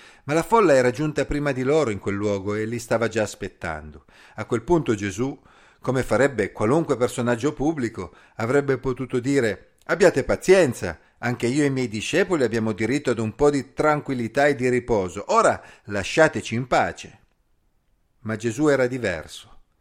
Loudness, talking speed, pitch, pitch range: -22 LUFS, 165 wpm, 125 Hz, 110-145 Hz